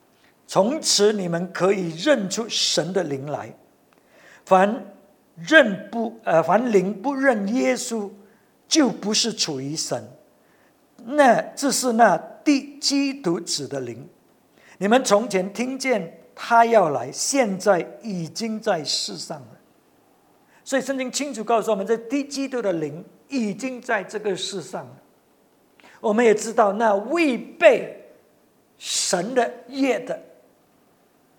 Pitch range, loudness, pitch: 195-260 Hz, -21 LUFS, 220 Hz